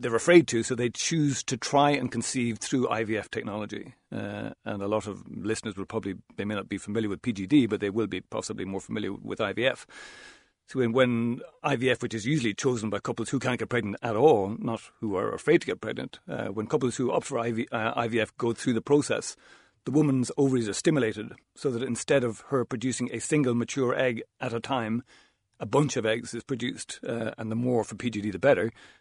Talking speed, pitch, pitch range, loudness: 215 wpm, 120 Hz, 110-130 Hz, -28 LUFS